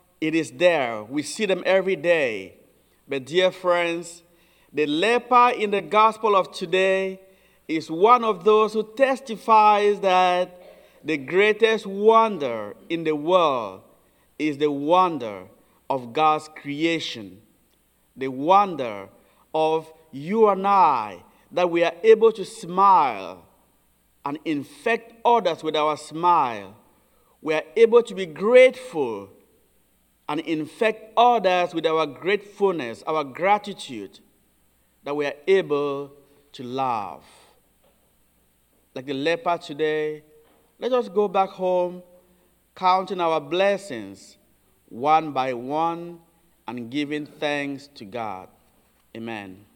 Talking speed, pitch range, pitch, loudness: 115 wpm, 150-200 Hz, 170 Hz, -22 LUFS